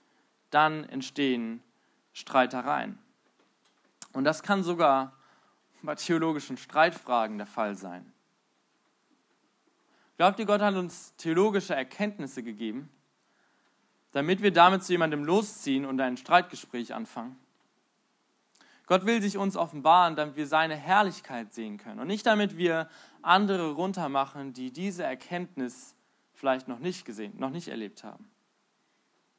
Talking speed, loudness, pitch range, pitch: 120 wpm, -28 LUFS, 135-190 Hz, 160 Hz